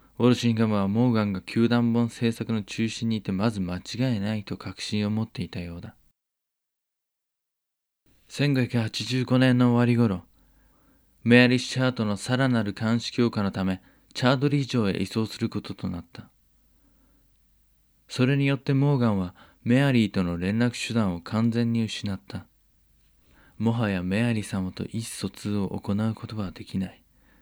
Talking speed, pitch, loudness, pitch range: 300 characters per minute, 110 Hz, -25 LUFS, 100-120 Hz